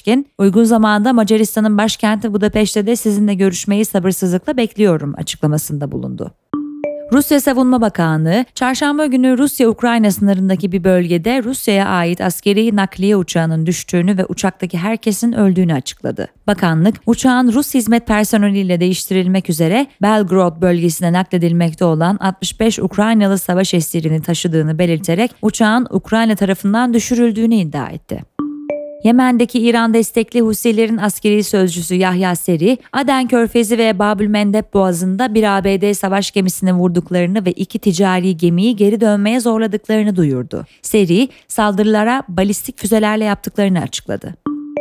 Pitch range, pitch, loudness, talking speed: 185-230 Hz, 210 Hz, -14 LUFS, 120 wpm